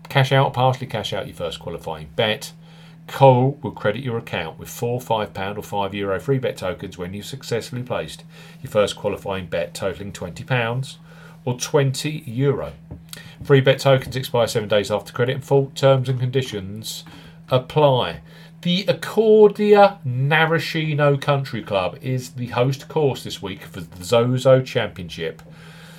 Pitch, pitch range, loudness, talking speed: 135 Hz, 115-160 Hz, -20 LUFS, 155 wpm